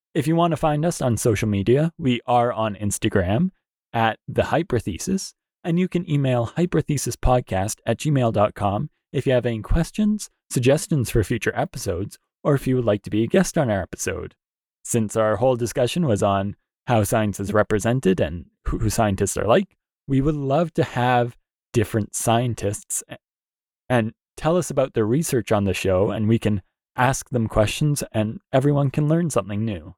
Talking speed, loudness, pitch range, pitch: 170 wpm, -22 LUFS, 110-145 Hz, 120 Hz